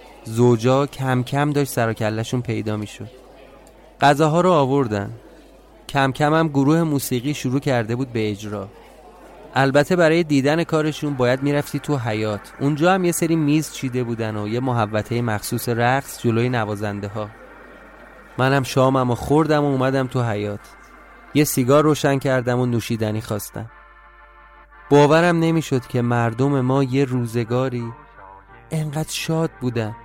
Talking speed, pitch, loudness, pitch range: 140 wpm, 130 Hz, -20 LUFS, 115-145 Hz